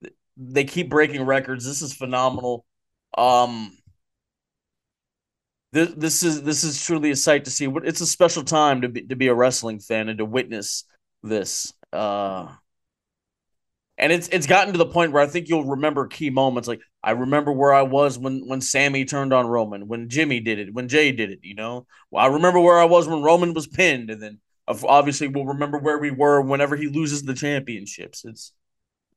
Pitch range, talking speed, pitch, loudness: 125-155 Hz, 195 wpm, 140 Hz, -20 LUFS